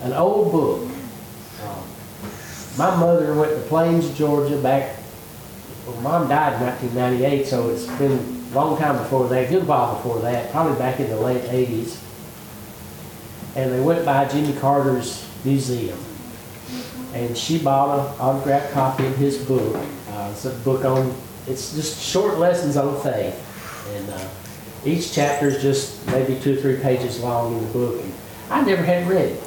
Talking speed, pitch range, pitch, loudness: 170 wpm, 120-145 Hz, 130 Hz, -21 LUFS